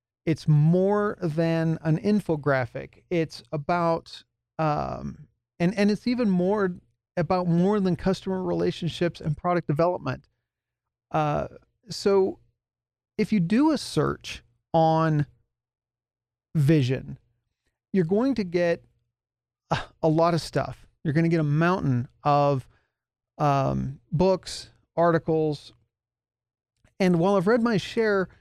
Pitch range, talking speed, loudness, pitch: 120-180 Hz, 115 wpm, -25 LUFS, 160 Hz